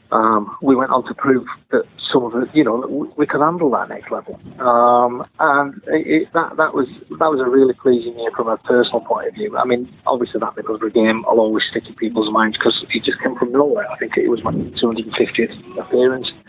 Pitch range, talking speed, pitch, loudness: 115-130 Hz, 235 wpm, 120 Hz, -17 LUFS